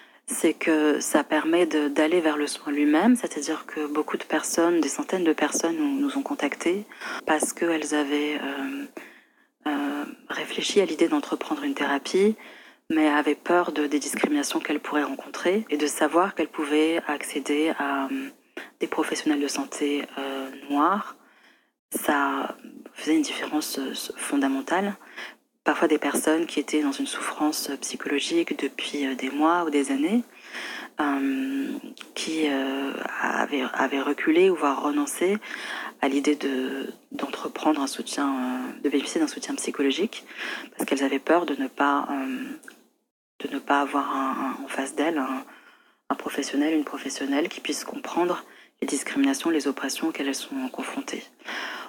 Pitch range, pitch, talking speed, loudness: 145-205 Hz, 155 Hz, 140 wpm, -26 LUFS